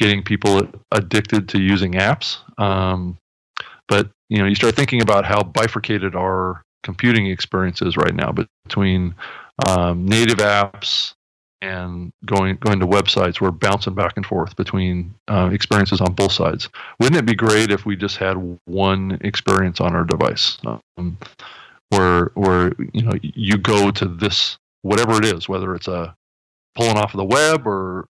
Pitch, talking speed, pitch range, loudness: 100 Hz, 165 wpm, 90-105 Hz, -18 LUFS